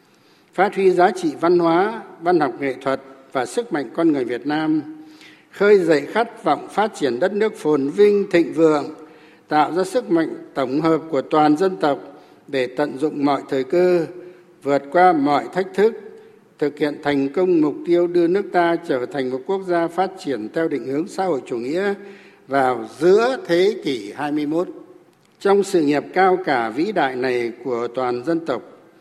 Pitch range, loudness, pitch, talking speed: 145-205 Hz, -20 LUFS, 175 Hz, 185 wpm